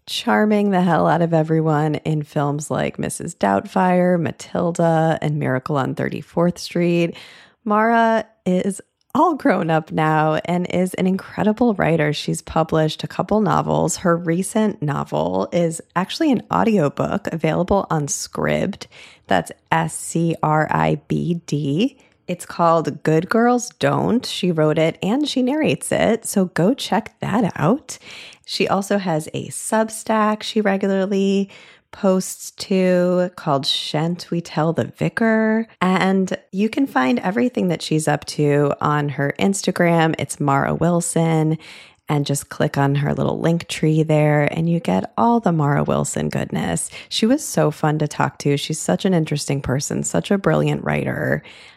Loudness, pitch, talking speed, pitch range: -19 LUFS, 170 Hz, 150 wpm, 150-200 Hz